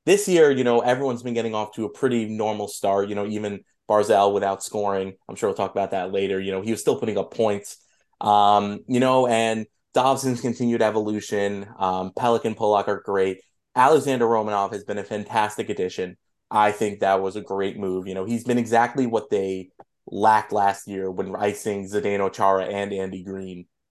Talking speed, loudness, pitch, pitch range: 195 wpm, -23 LUFS, 105 Hz, 95-115 Hz